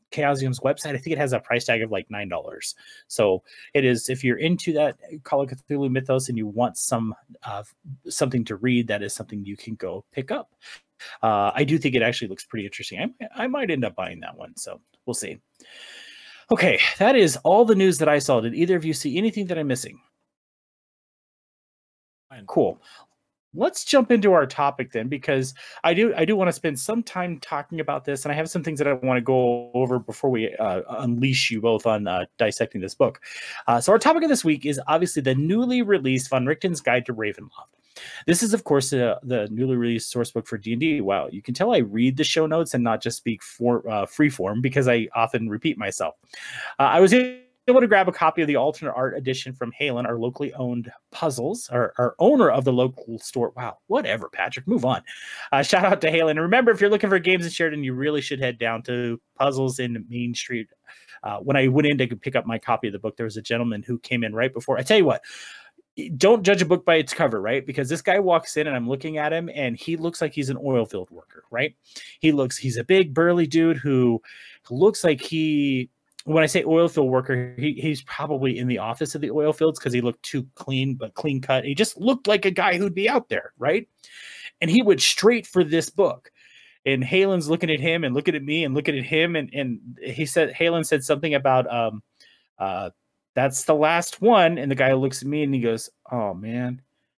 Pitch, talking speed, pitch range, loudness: 140 Hz, 230 wpm, 125-165 Hz, -22 LUFS